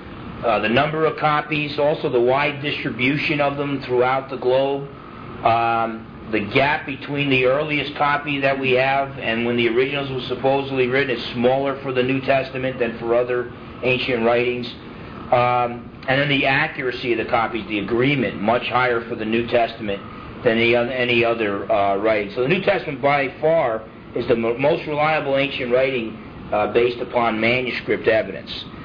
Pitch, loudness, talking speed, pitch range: 125 Hz, -20 LUFS, 175 wpm, 120-140 Hz